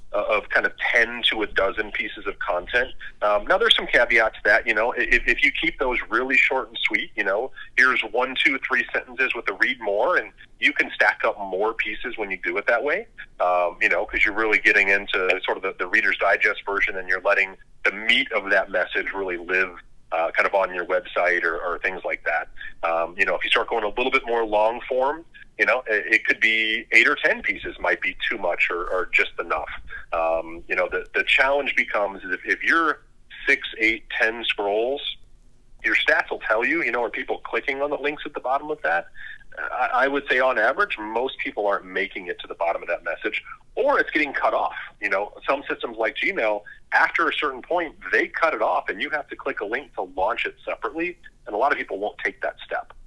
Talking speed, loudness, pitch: 235 wpm, -22 LUFS, 135 Hz